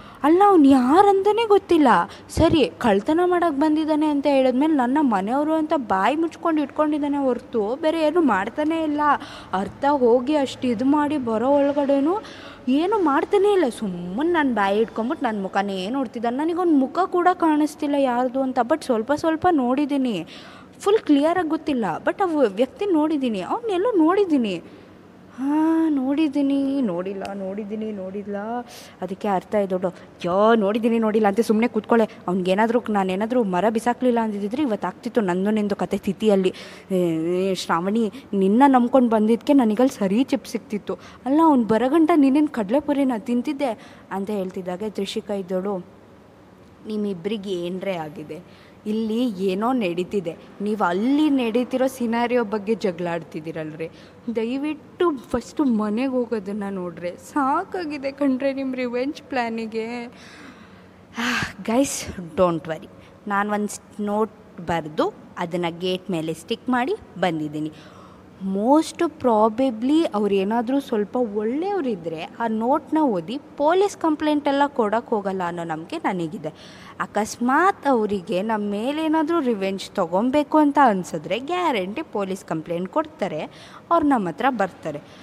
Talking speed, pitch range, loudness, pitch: 120 wpm, 200-290 Hz, -22 LUFS, 240 Hz